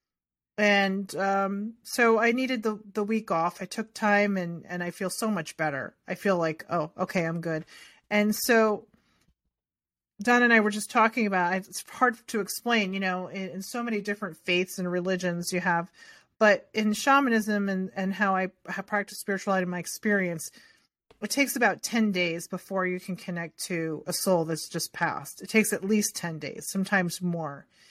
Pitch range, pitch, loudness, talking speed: 180-215 Hz, 195 Hz, -27 LUFS, 190 wpm